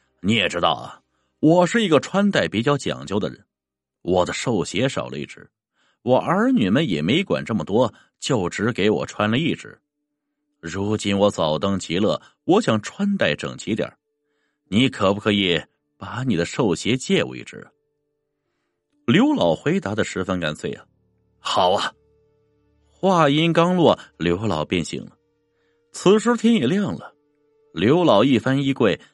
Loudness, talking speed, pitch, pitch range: -20 LUFS, 215 characters per minute, 145 Hz, 95-155 Hz